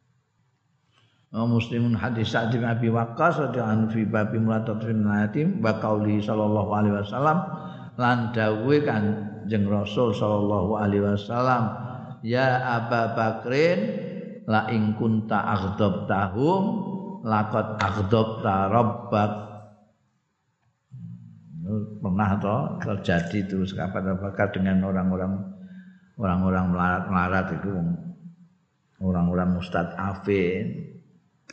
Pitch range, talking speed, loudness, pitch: 100-120 Hz, 95 wpm, -25 LUFS, 110 Hz